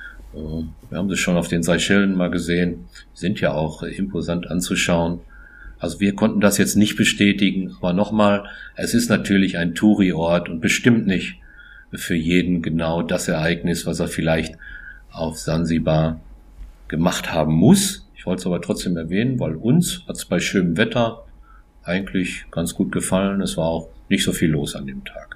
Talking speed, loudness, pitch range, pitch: 170 wpm, -20 LUFS, 80-100 Hz, 85 Hz